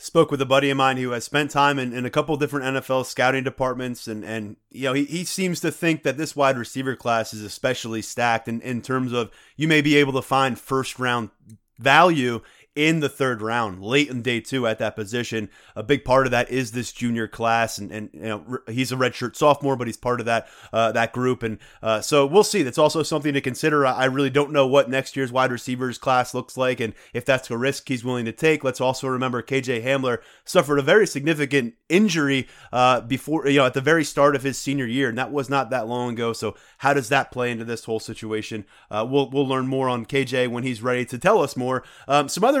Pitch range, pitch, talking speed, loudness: 120-140 Hz, 130 Hz, 240 wpm, -22 LUFS